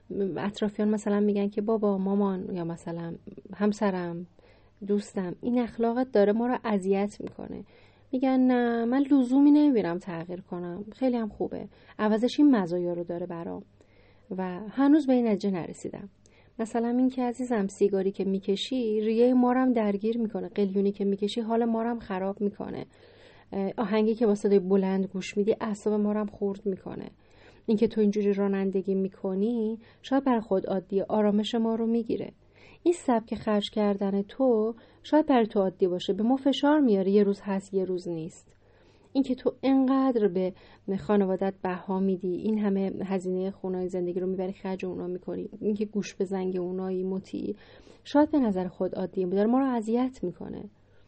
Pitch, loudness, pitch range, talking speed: 205 Hz, -27 LUFS, 190-230 Hz, 160 wpm